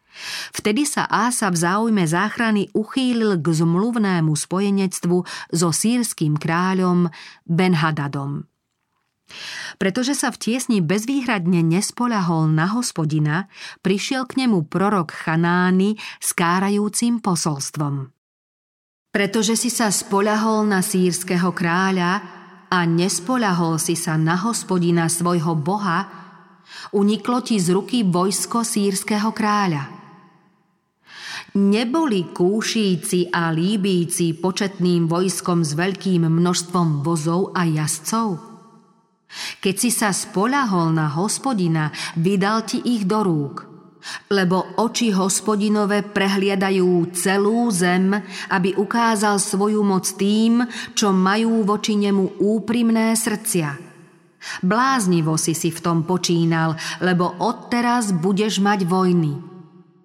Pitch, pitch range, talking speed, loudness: 190 Hz, 175-215 Hz, 105 wpm, -20 LUFS